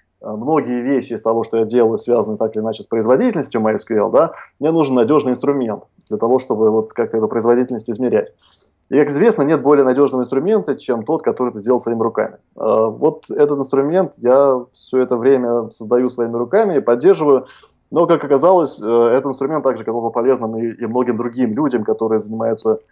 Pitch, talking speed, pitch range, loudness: 125 Hz, 175 wpm, 115-140 Hz, -16 LUFS